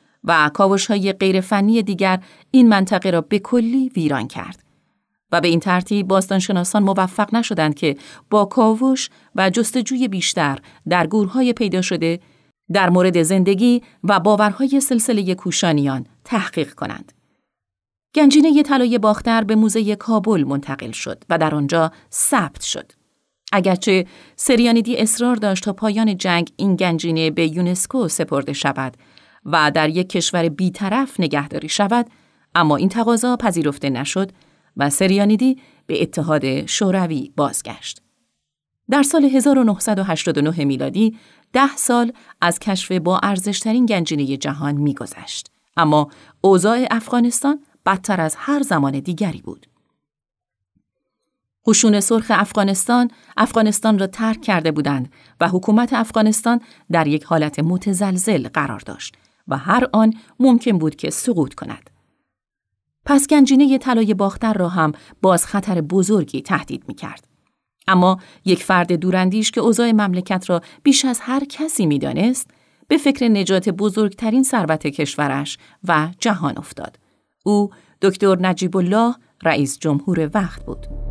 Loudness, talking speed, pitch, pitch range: -17 LUFS, 130 wpm, 195 Hz, 165-225 Hz